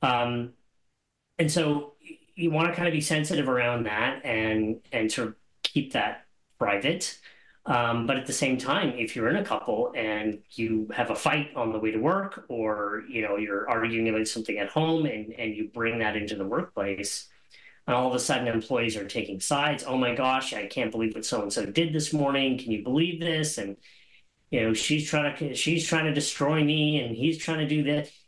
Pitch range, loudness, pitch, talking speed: 110-155 Hz, -27 LUFS, 130 Hz, 210 wpm